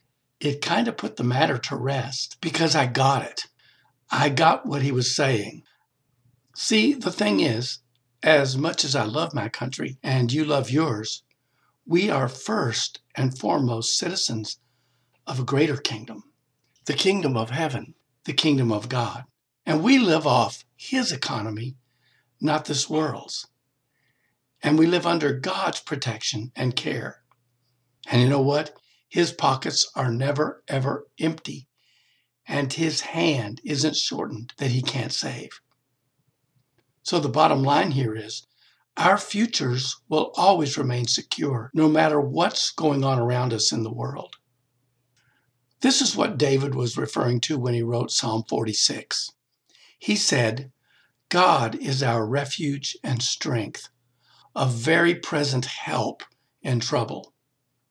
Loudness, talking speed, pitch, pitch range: -23 LUFS, 140 wpm, 135 Hz, 125-150 Hz